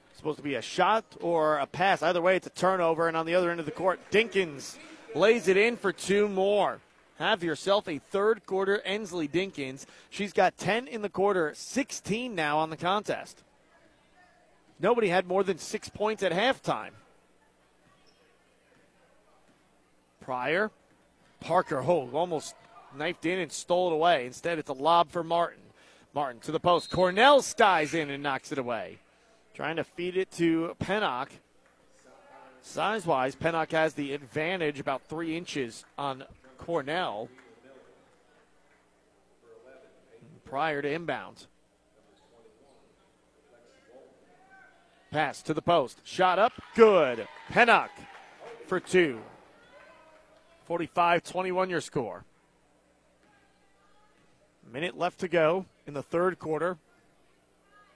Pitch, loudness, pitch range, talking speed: 175 Hz, -28 LUFS, 155-195 Hz, 130 wpm